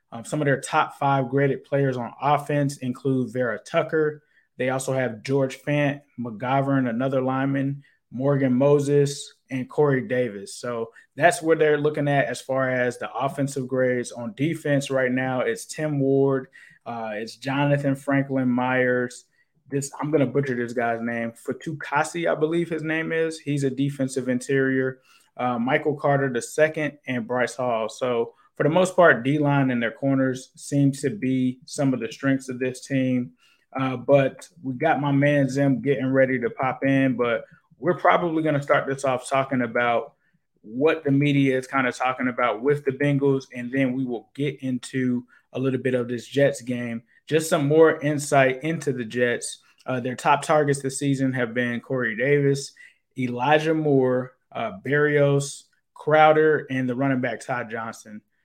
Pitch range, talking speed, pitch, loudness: 125-145 Hz, 170 wpm, 135 Hz, -23 LUFS